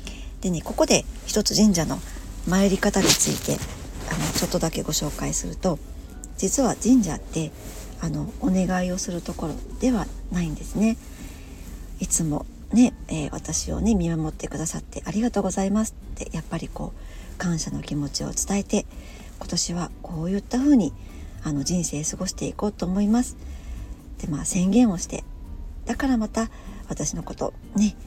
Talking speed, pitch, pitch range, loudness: 285 characters per minute, 190 Hz, 160-215 Hz, -24 LUFS